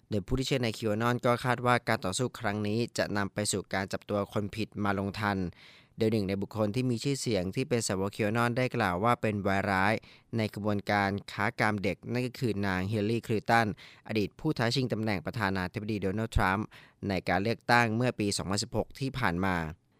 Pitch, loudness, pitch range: 105 Hz, -30 LUFS, 100-115 Hz